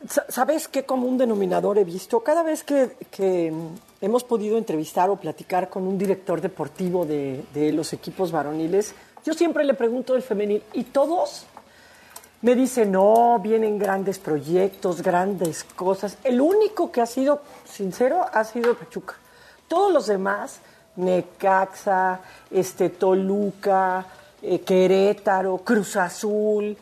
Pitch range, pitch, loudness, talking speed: 185-240 Hz, 200 Hz, -23 LUFS, 130 wpm